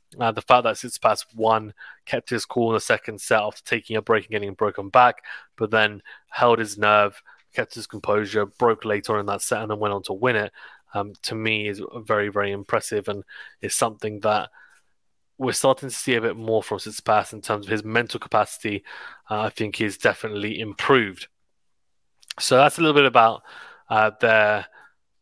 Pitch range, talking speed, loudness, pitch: 105-115 Hz, 200 wpm, -22 LUFS, 110 Hz